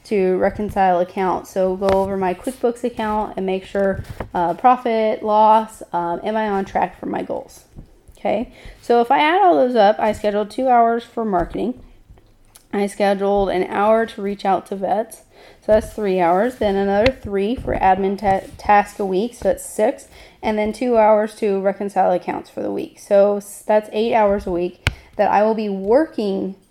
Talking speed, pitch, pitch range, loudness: 185 wpm, 205 Hz, 190-220 Hz, -19 LUFS